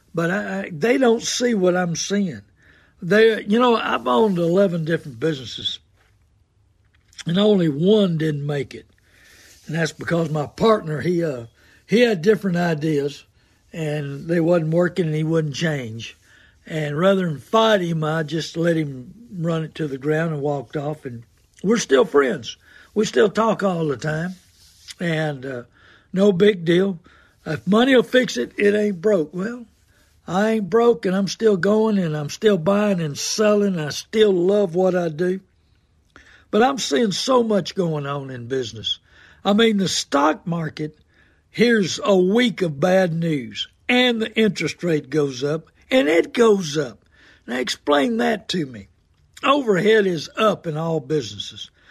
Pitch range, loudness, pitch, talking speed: 145-205 Hz, -20 LUFS, 170 Hz, 165 wpm